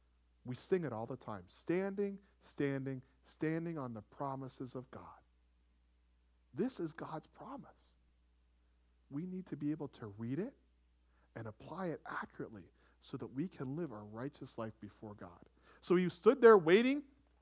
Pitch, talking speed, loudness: 125 Hz, 155 wpm, -37 LUFS